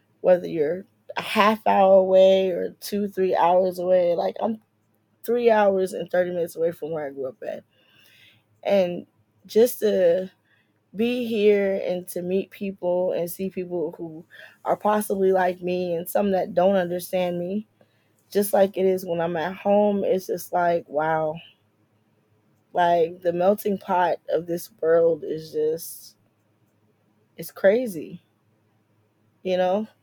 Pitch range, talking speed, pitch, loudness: 145-195 Hz, 145 wpm, 180 Hz, -23 LUFS